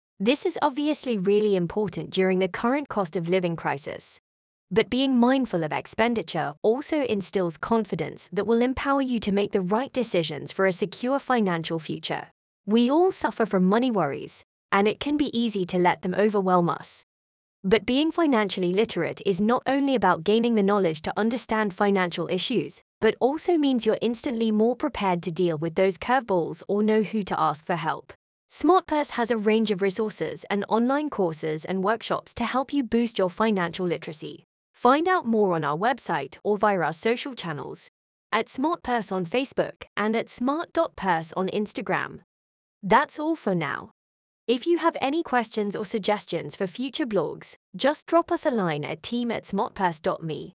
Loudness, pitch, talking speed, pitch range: -25 LUFS, 215 Hz, 170 wpm, 185-250 Hz